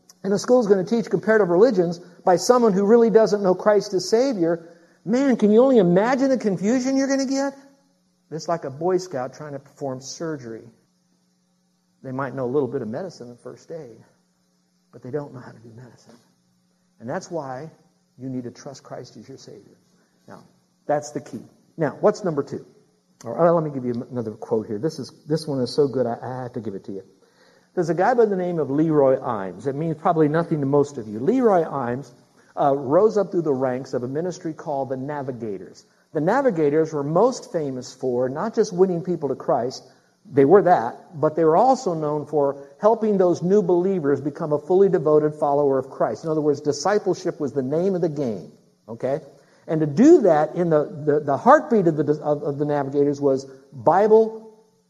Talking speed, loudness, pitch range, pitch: 210 wpm, -21 LUFS, 135-185 Hz, 155 Hz